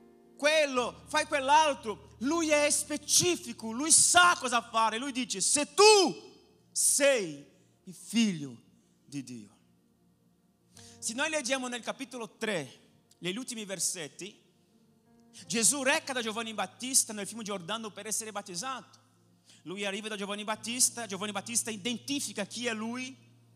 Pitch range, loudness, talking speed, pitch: 190-265 Hz, -28 LUFS, 125 wpm, 225 Hz